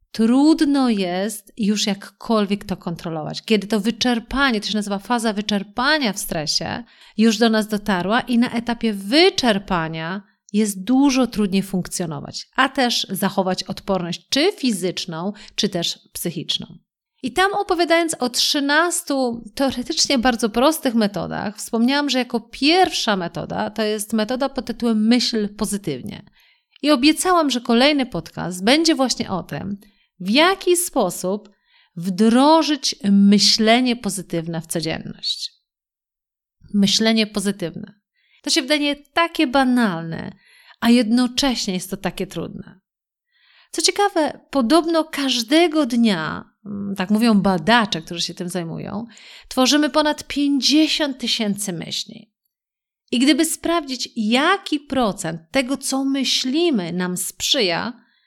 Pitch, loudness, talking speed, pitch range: 230 Hz, -19 LUFS, 120 wpm, 195-275 Hz